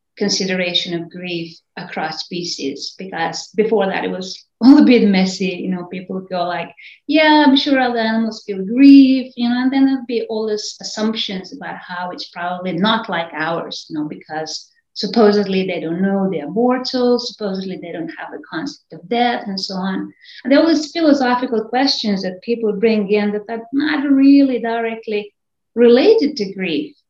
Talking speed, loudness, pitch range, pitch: 180 wpm, -16 LUFS, 180-245 Hz, 210 Hz